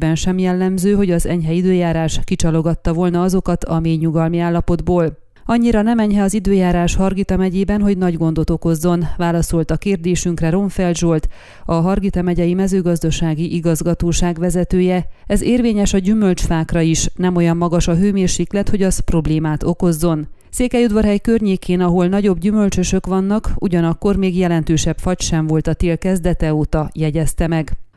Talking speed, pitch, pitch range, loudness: 145 wpm, 175 Hz, 165-190 Hz, -17 LUFS